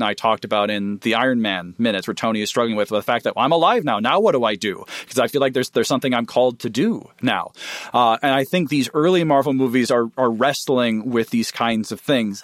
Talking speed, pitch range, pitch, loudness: 260 wpm, 110-130 Hz, 120 Hz, -19 LUFS